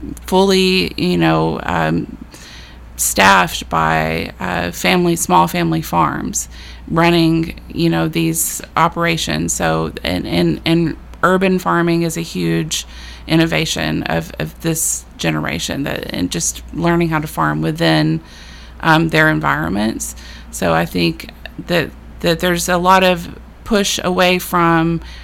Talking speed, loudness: 125 wpm, -16 LUFS